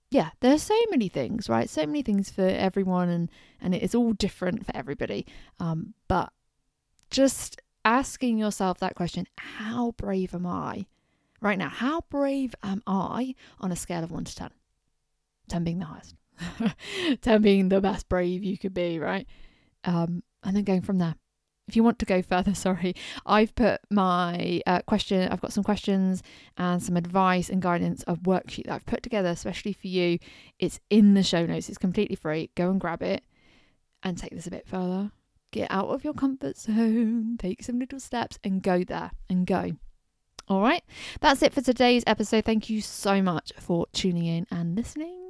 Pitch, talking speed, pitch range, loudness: 195 Hz, 185 wpm, 180-230 Hz, -27 LUFS